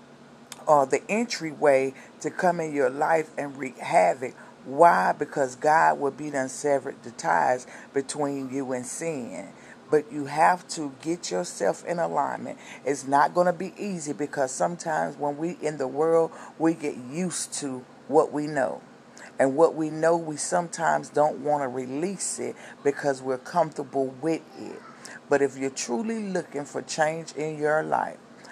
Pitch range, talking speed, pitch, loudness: 140-165 Hz, 160 wpm, 150 Hz, -26 LUFS